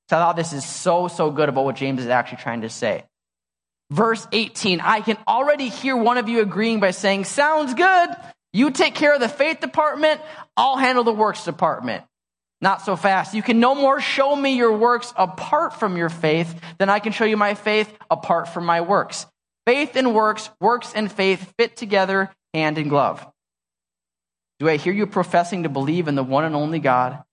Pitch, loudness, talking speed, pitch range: 195 Hz, -20 LUFS, 200 wpm, 155-240 Hz